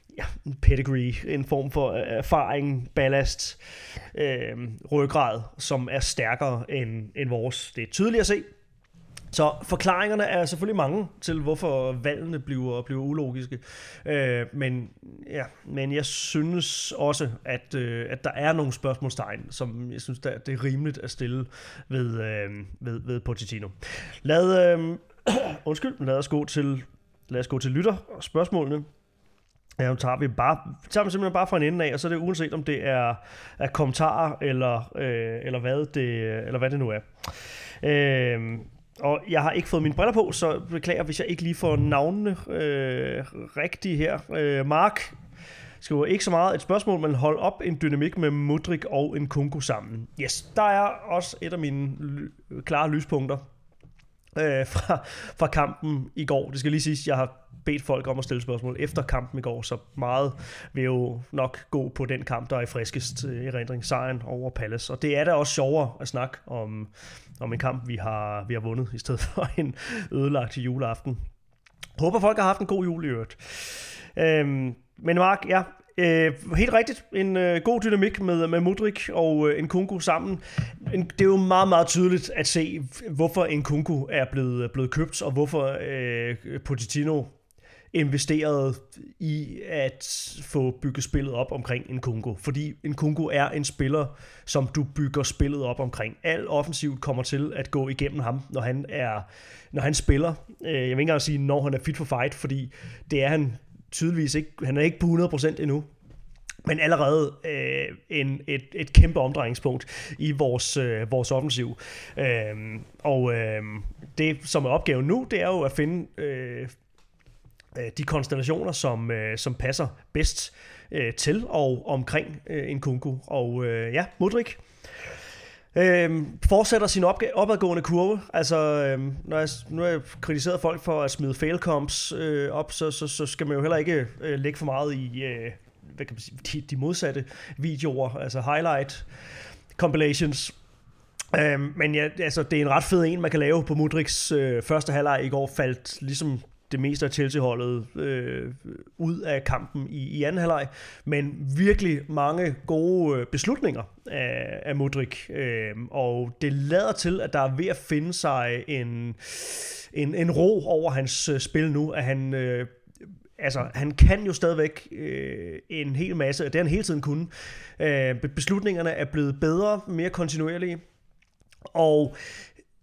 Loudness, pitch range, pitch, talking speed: -26 LUFS, 130-160 Hz, 145 Hz, 170 wpm